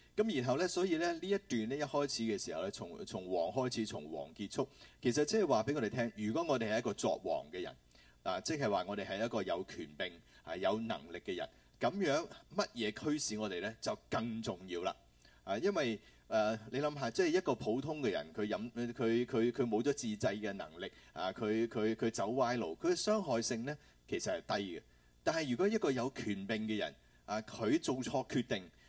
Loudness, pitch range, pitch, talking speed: -37 LUFS, 110-150 Hz, 120 Hz, 295 characters per minute